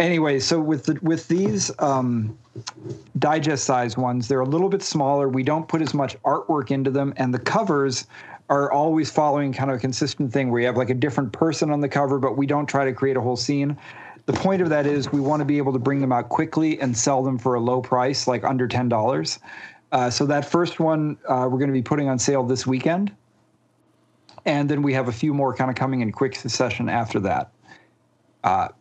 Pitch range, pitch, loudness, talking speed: 130-150 Hz, 140 Hz, -22 LUFS, 225 wpm